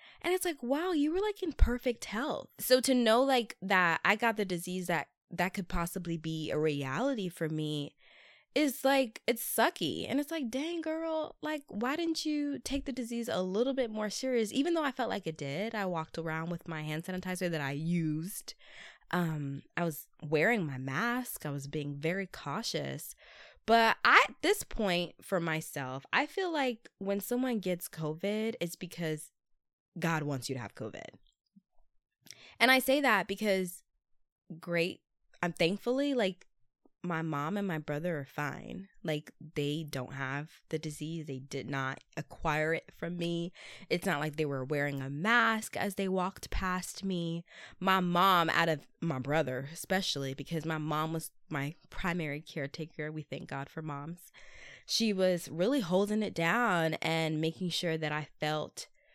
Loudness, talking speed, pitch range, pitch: -33 LUFS, 175 wpm, 155-225 Hz, 175 Hz